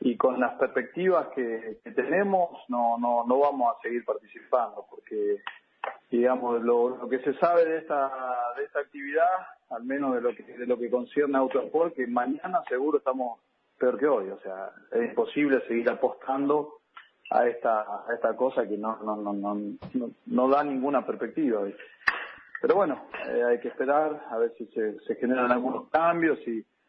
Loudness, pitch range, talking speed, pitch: -27 LUFS, 120-170 Hz, 180 wpm, 135 Hz